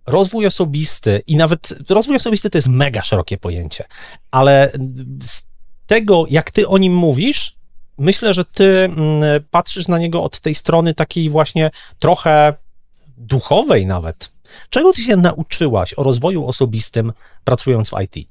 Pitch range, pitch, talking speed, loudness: 130-180 Hz, 155 Hz, 140 wpm, -15 LUFS